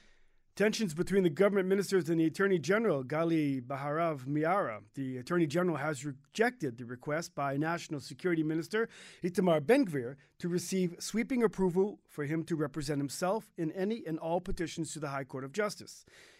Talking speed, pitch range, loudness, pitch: 165 wpm, 150-190 Hz, -33 LUFS, 165 Hz